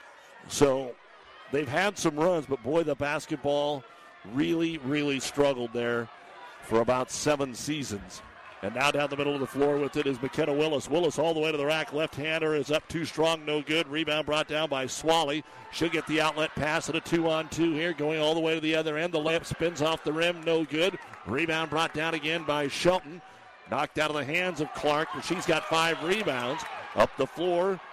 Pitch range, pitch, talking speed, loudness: 145-160 Hz, 155 Hz, 205 wpm, -28 LUFS